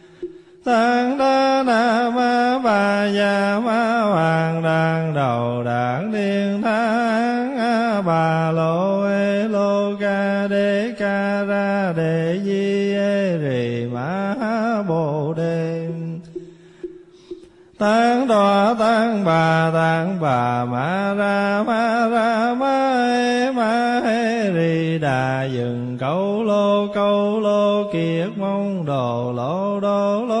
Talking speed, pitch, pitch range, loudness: 115 wpm, 200 Hz, 165-225 Hz, -19 LUFS